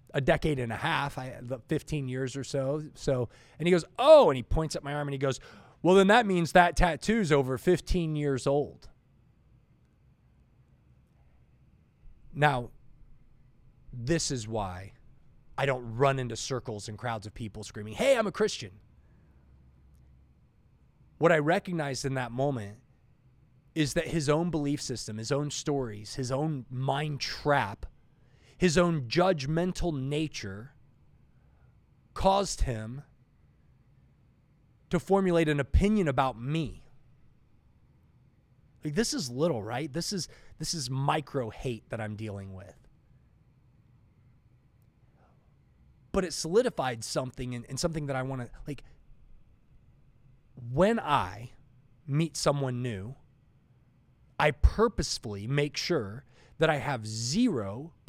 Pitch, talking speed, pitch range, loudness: 135 Hz, 125 wpm, 120-155 Hz, -29 LUFS